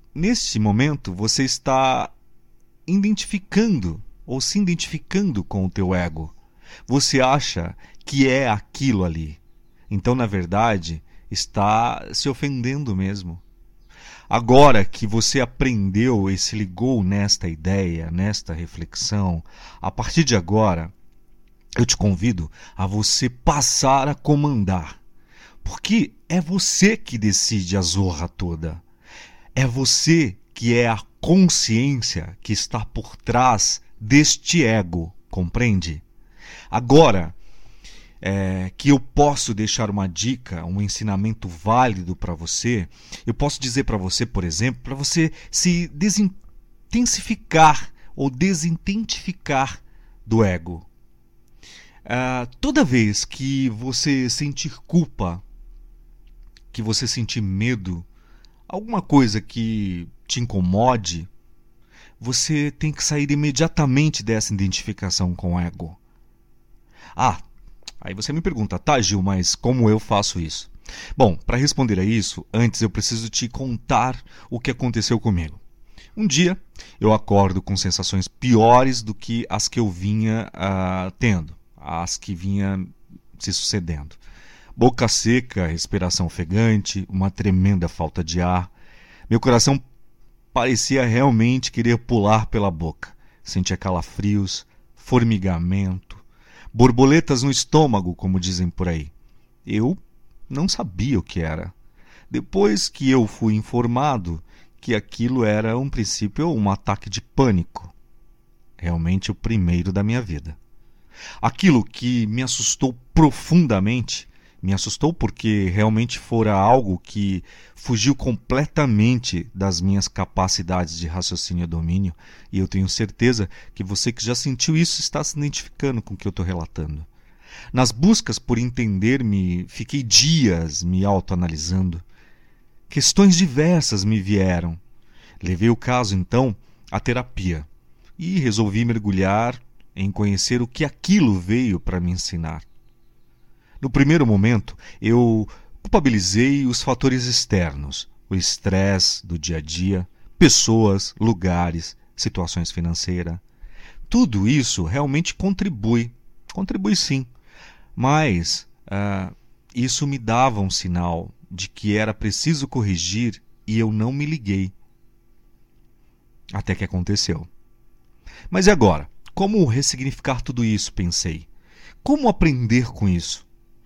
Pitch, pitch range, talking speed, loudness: 110 Hz, 95-130 Hz, 120 wpm, -20 LUFS